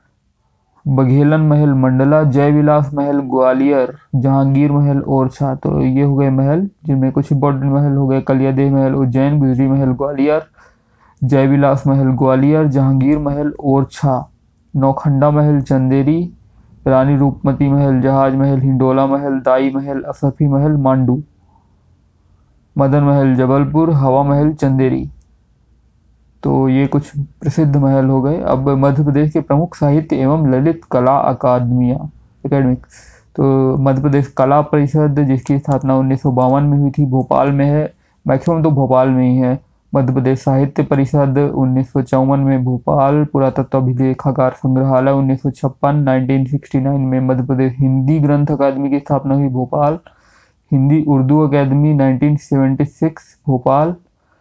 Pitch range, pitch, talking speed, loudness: 130-145 Hz, 135 Hz, 135 wpm, -14 LUFS